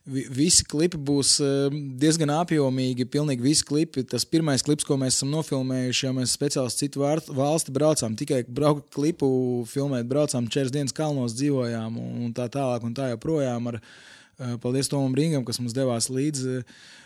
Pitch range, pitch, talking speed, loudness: 125-145 Hz, 135 Hz, 150 wpm, -24 LUFS